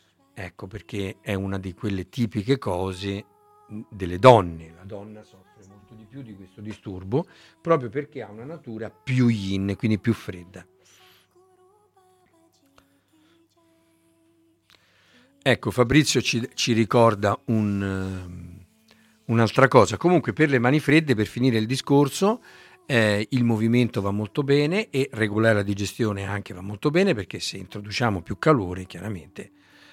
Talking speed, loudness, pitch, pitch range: 135 wpm, -23 LUFS, 115 Hz, 100-140 Hz